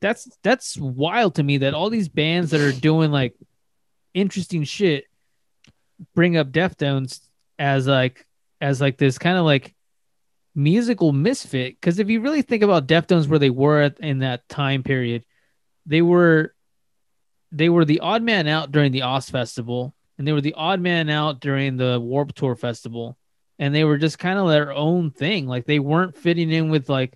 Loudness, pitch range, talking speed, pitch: -20 LUFS, 135-170 Hz, 180 wpm, 150 Hz